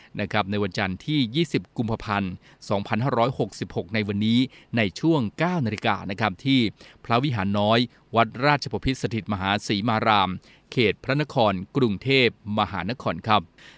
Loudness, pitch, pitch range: -24 LUFS, 115 Hz, 105-135 Hz